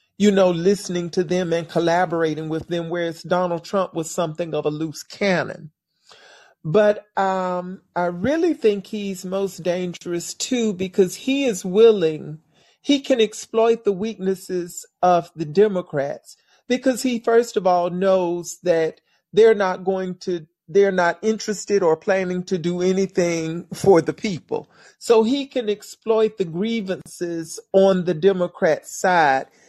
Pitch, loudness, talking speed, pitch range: 185 Hz, -21 LUFS, 145 wpm, 175-210 Hz